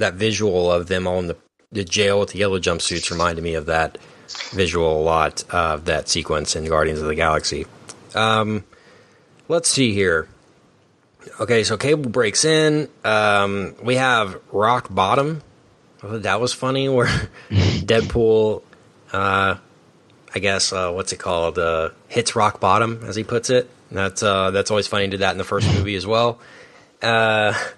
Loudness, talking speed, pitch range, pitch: -20 LUFS, 170 wpm, 95-120 Hz, 105 Hz